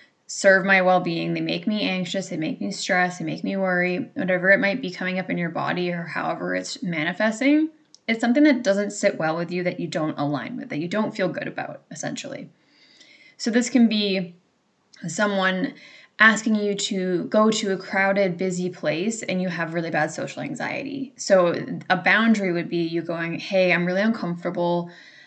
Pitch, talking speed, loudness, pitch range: 190 Hz, 190 wpm, -23 LUFS, 175-215 Hz